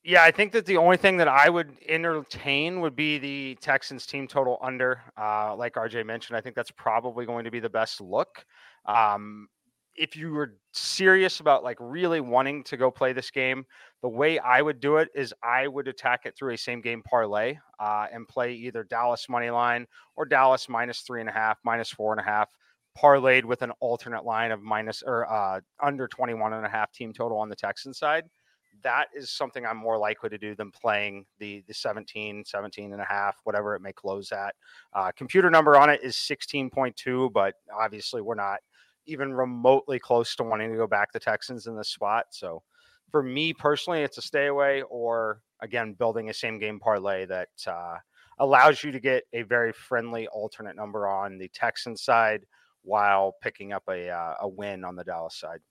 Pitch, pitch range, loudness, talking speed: 120 Hz, 105-140 Hz, -26 LUFS, 205 wpm